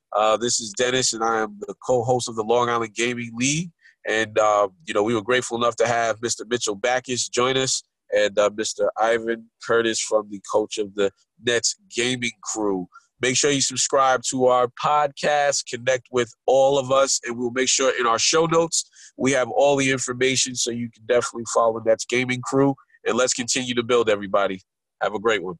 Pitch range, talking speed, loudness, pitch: 115-130 Hz, 205 wpm, -22 LUFS, 120 Hz